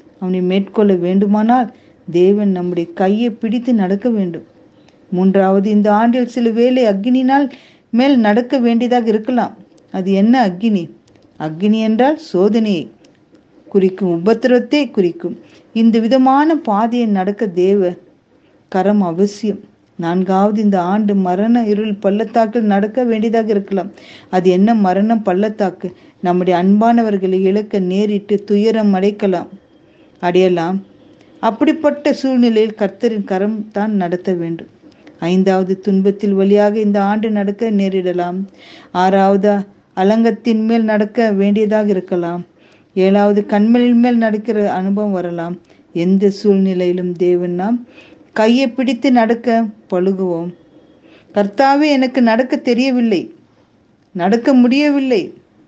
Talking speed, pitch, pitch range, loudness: 100 wpm, 205 Hz, 190-235 Hz, -14 LUFS